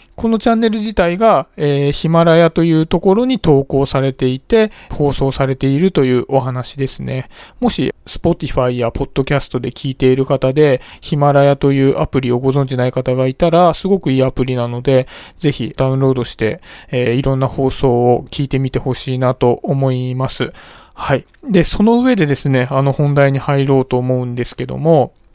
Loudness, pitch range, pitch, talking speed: -15 LUFS, 130-160 Hz, 135 Hz, 375 characters per minute